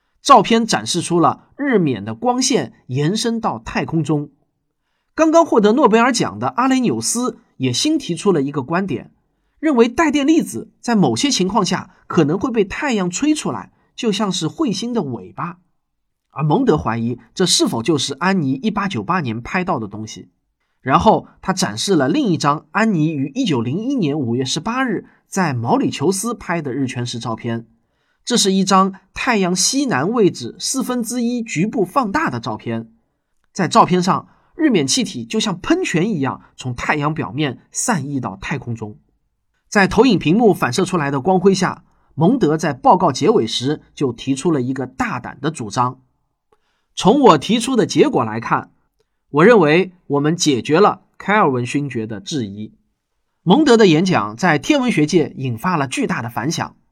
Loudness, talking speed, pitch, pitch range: -17 LUFS, 245 characters per minute, 175 Hz, 135-225 Hz